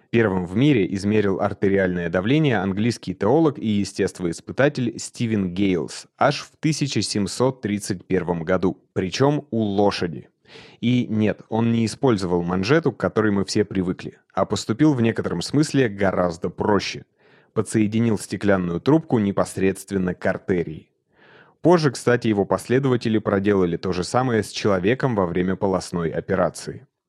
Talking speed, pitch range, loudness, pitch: 130 wpm, 95-115 Hz, -22 LUFS, 105 Hz